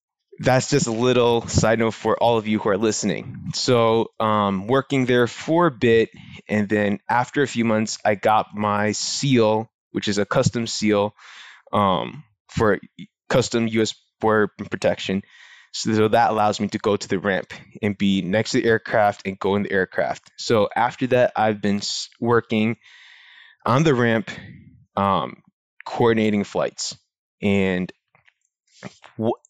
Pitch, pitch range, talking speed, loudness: 110 Hz, 105-125 Hz, 155 wpm, -21 LUFS